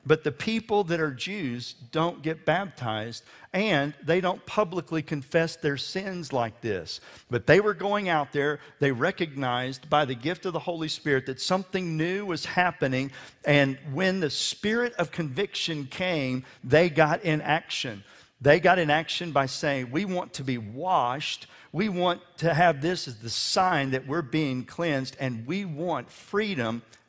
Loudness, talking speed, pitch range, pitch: -27 LUFS, 170 wpm, 135-175 Hz, 155 Hz